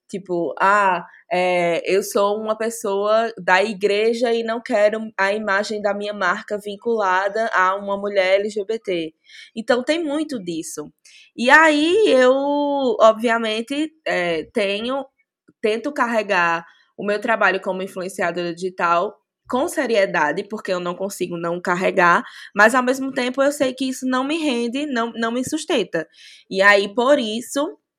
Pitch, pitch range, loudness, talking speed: 220 Hz, 195-255 Hz, -19 LUFS, 145 wpm